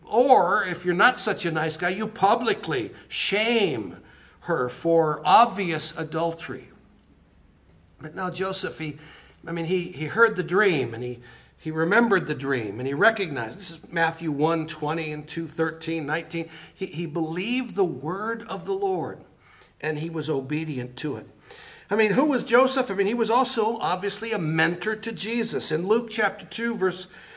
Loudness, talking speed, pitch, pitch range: -25 LUFS, 170 wpm, 175 Hz, 155-215 Hz